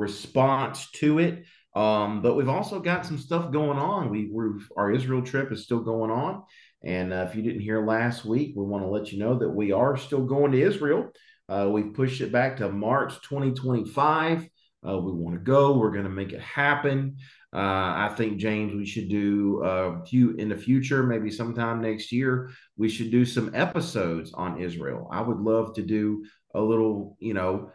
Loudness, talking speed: -26 LUFS, 200 wpm